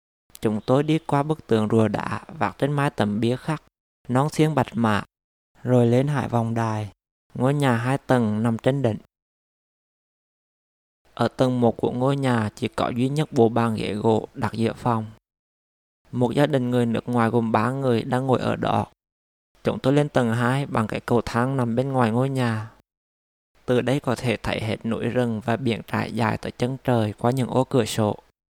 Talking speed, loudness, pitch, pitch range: 200 wpm, -23 LUFS, 120 Hz, 110-130 Hz